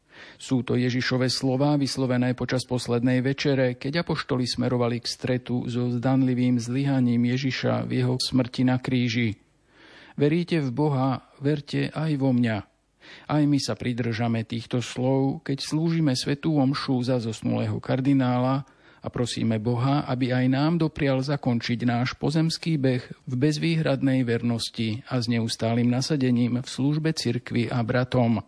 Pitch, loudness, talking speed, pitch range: 130 Hz, -25 LUFS, 135 wpm, 120-140 Hz